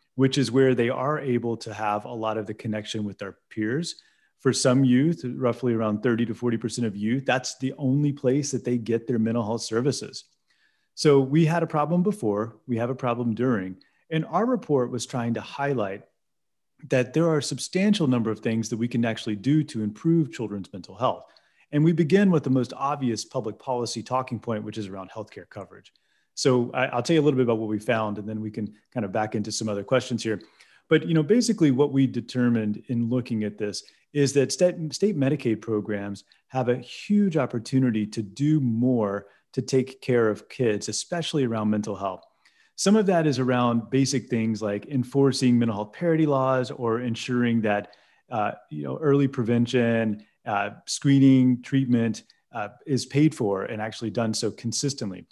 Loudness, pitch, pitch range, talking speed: -25 LUFS, 120 Hz, 110-135 Hz, 195 wpm